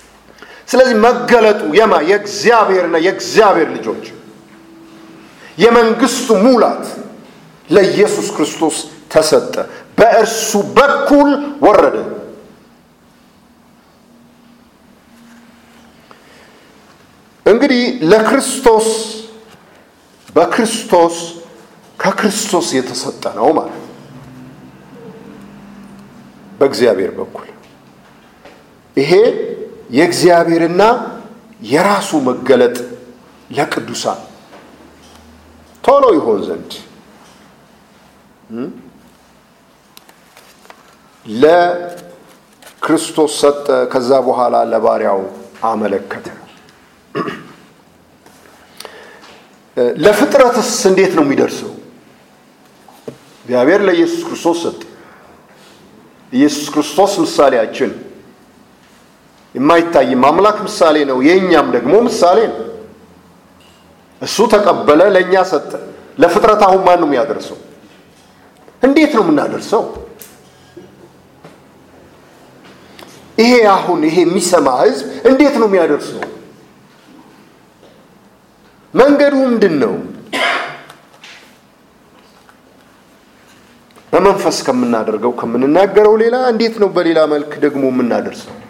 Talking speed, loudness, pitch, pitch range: 60 wpm, -12 LUFS, 210 Hz, 160-235 Hz